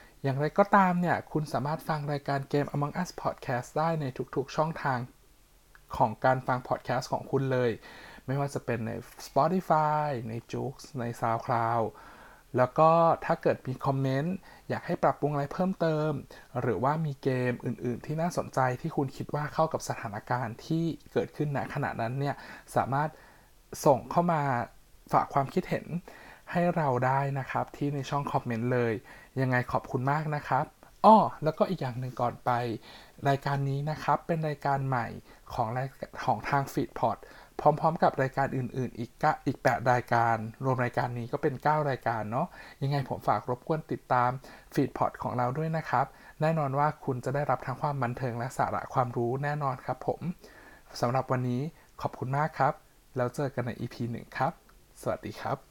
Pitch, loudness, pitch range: 135 Hz, -30 LUFS, 125-150 Hz